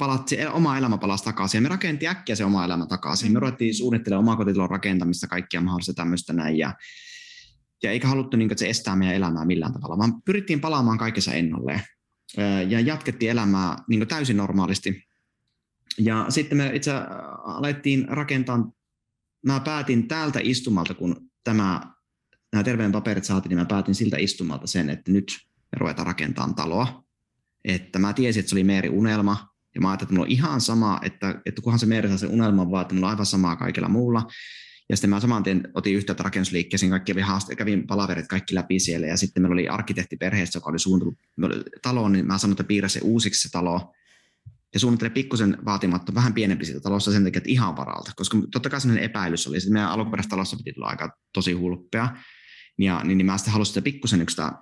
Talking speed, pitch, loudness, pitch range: 190 wpm, 100 Hz, -24 LUFS, 95-120 Hz